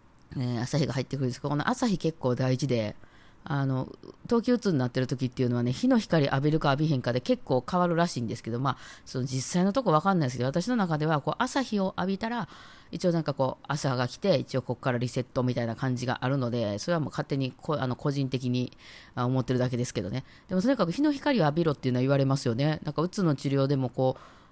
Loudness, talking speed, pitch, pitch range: -28 LUFS, 485 characters per minute, 140 Hz, 125-170 Hz